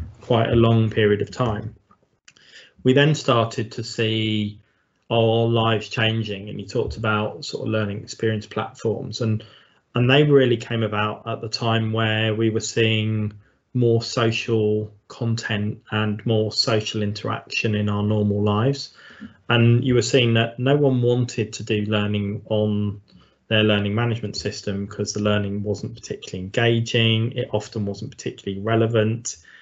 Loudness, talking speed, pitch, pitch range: -22 LUFS, 150 wpm, 110 Hz, 105-115 Hz